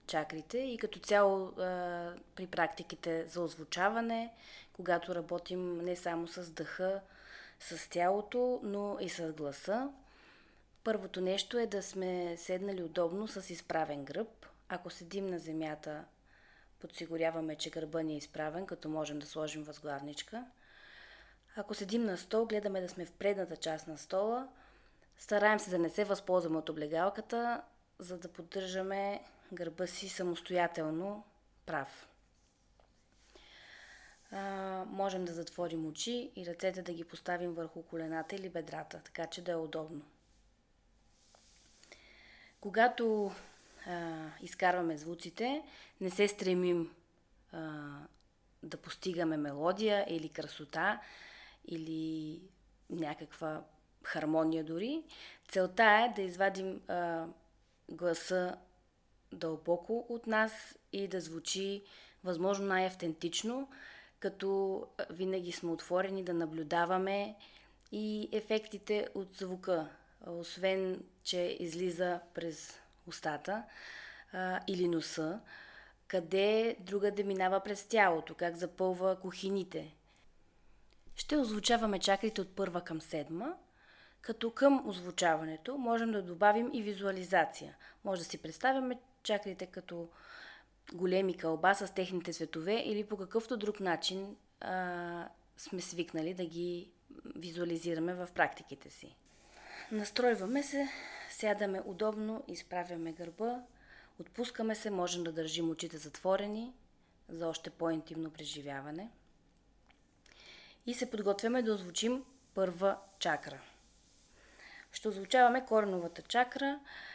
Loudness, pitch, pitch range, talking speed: -36 LUFS, 185 Hz, 165-210 Hz, 110 wpm